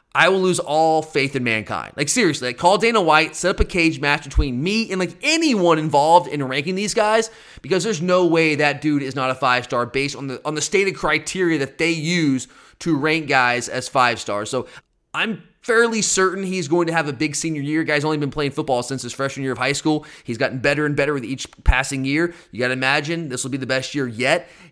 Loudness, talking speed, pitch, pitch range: -19 LUFS, 240 wpm, 155 Hz, 135-175 Hz